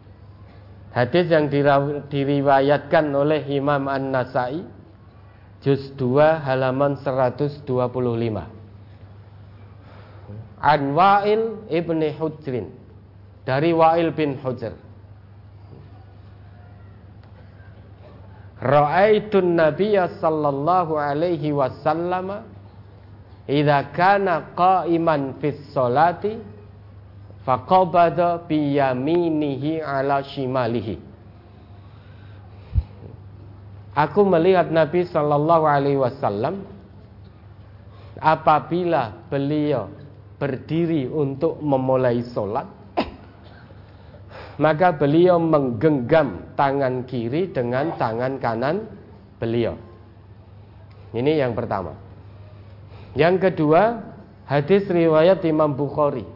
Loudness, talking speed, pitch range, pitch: -20 LUFS, 65 wpm, 100-155 Hz, 130 Hz